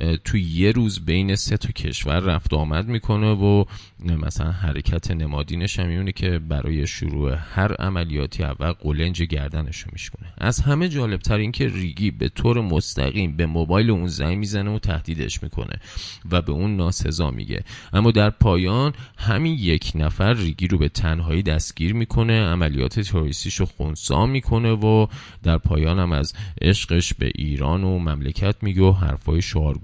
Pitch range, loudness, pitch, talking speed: 80-105 Hz, -22 LUFS, 90 Hz, 155 wpm